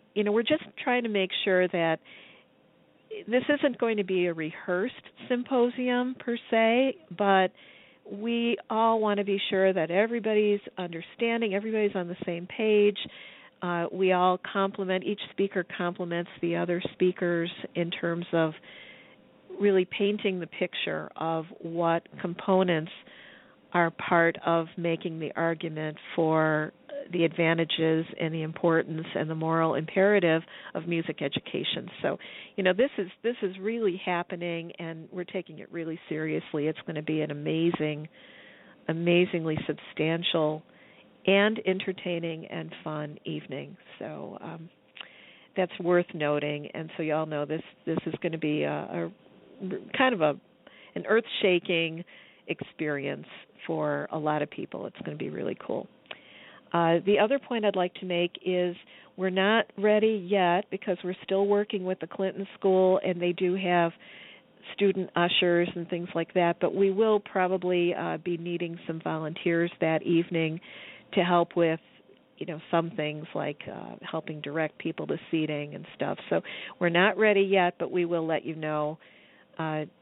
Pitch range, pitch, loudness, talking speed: 165-200 Hz, 175 Hz, -28 LUFS, 155 wpm